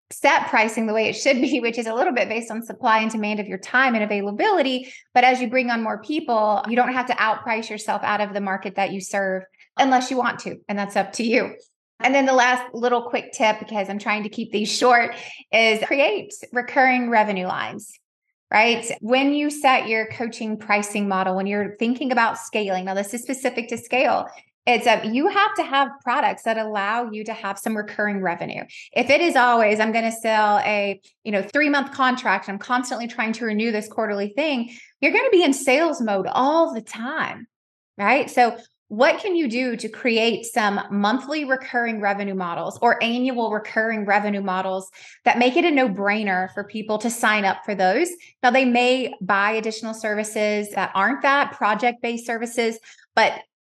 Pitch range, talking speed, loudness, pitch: 210-255 Hz, 200 wpm, -21 LUFS, 225 Hz